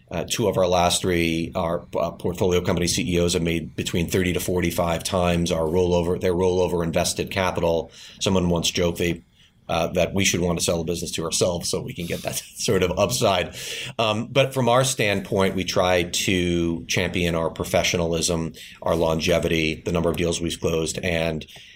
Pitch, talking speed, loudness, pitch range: 85 Hz, 185 wpm, -22 LUFS, 85-90 Hz